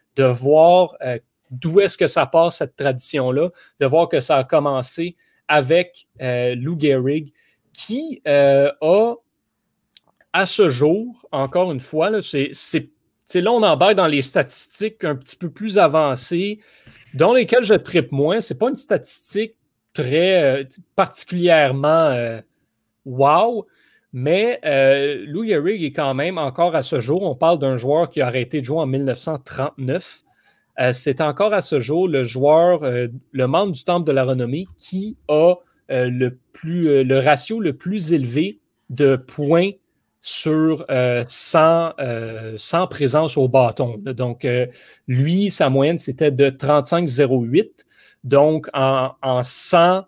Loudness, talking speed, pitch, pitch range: -18 LUFS, 155 wpm, 150 Hz, 130-175 Hz